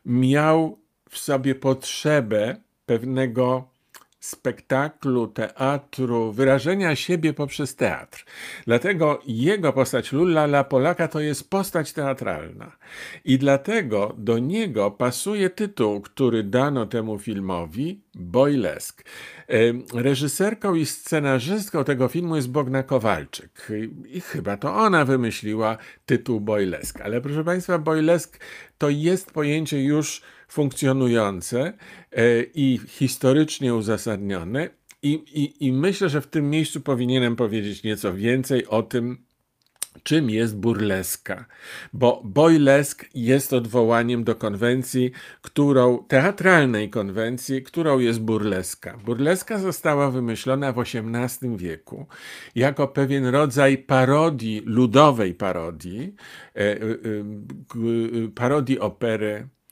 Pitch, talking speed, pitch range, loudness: 130 Hz, 100 wpm, 115-150 Hz, -22 LUFS